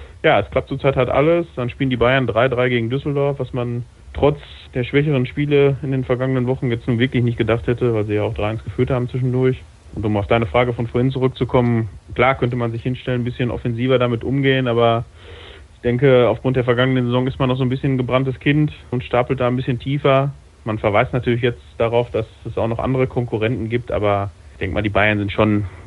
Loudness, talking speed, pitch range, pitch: -19 LUFS, 225 wpm, 115-130 Hz, 125 Hz